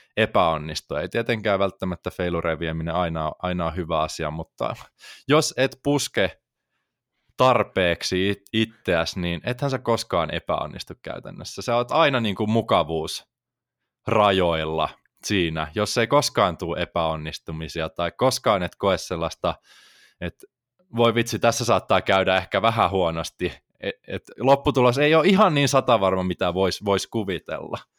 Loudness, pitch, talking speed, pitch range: -23 LUFS, 95 Hz, 130 wpm, 85-115 Hz